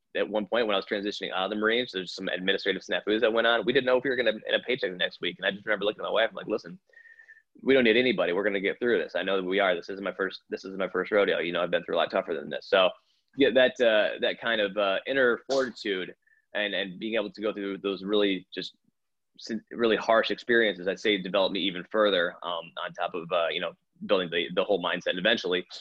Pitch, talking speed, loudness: 105 Hz, 280 wpm, -27 LUFS